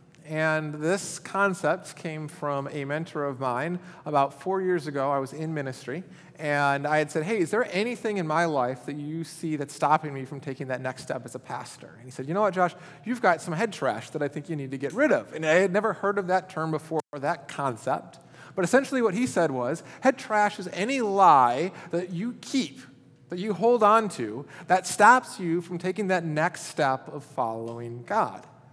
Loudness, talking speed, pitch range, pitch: -26 LUFS, 220 wpm, 140-185 Hz, 160 Hz